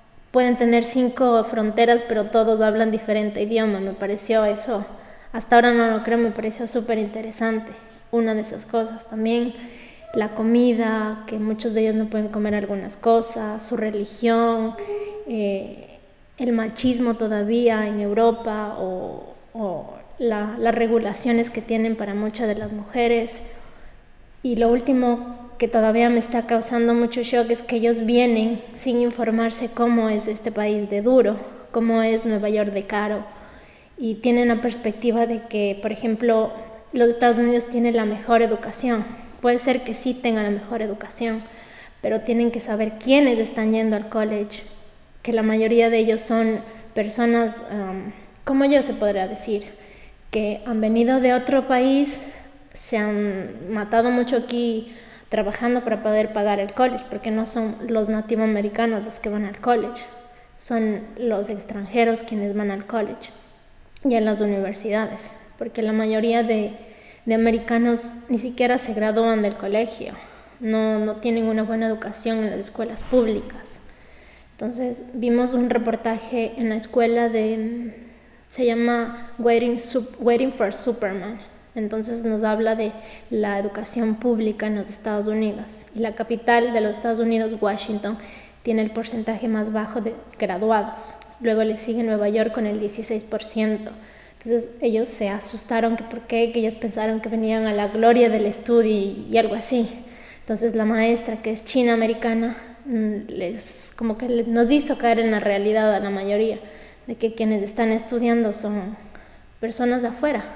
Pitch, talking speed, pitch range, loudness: 225 Hz, 155 wpm, 215-235 Hz, -22 LUFS